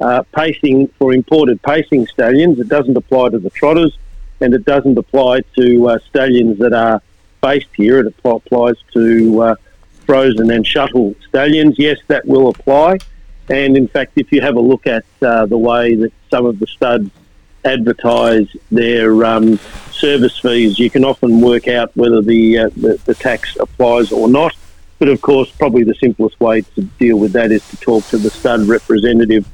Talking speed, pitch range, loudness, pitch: 180 wpm, 115-135 Hz, -12 LUFS, 120 Hz